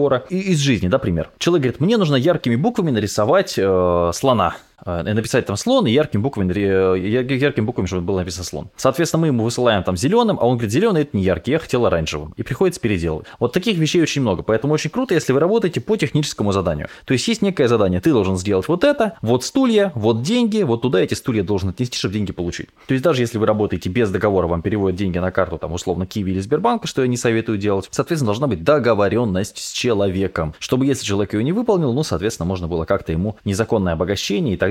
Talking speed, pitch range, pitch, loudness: 220 wpm, 95-145 Hz, 115 Hz, -19 LUFS